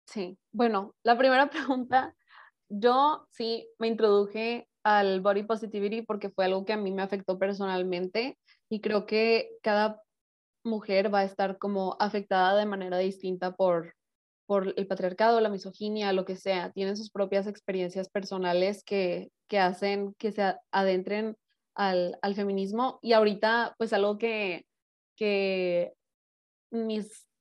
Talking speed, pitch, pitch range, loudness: 140 wpm, 205 Hz, 190-220 Hz, -28 LUFS